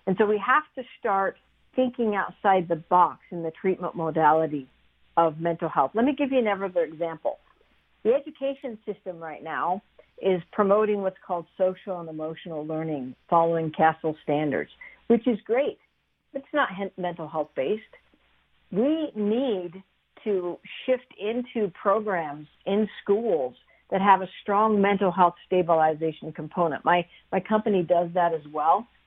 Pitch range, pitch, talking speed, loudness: 165-215 Hz, 190 Hz, 140 wpm, -26 LUFS